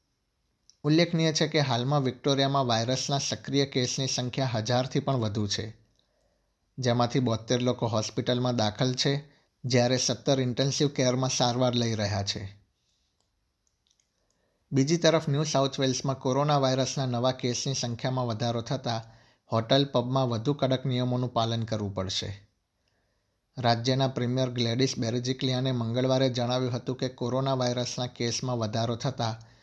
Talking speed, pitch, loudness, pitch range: 120 wpm, 125 Hz, -27 LUFS, 115-135 Hz